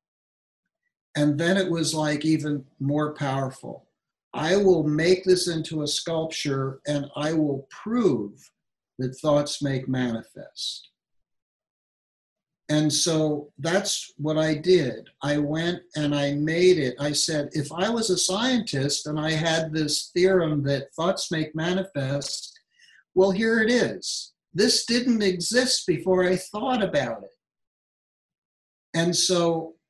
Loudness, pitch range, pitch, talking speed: -24 LUFS, 145-185 Hz, 155 Hz, 130 wpm